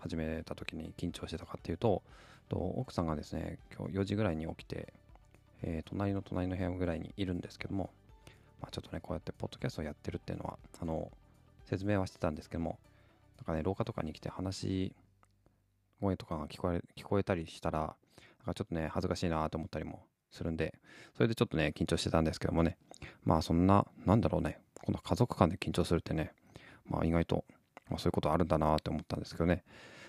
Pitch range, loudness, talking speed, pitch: 80-100 Hz, -36 LUFS, 460 characters per minute, 90 Hz